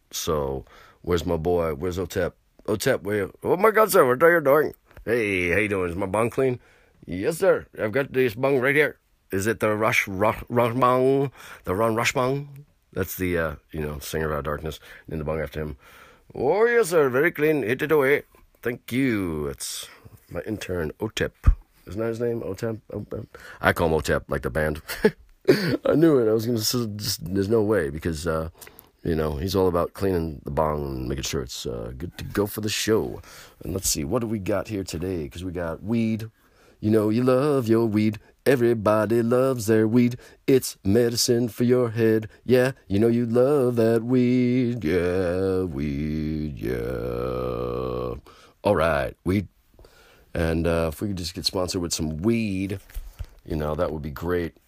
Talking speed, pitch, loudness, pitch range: 190 wpm, 100 Hz, -24 LUFS, 80-120 Hz